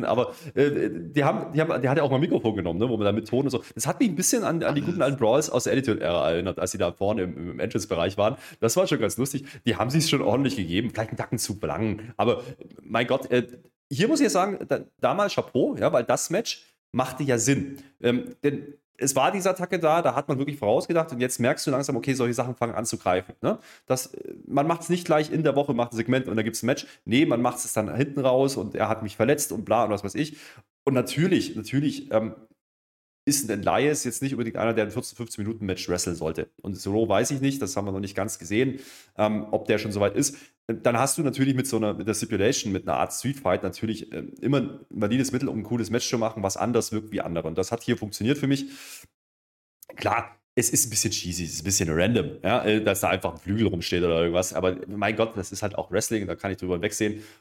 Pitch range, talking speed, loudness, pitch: 100-135 Hz, 260 wpm, -25 LUFS, 115 Hz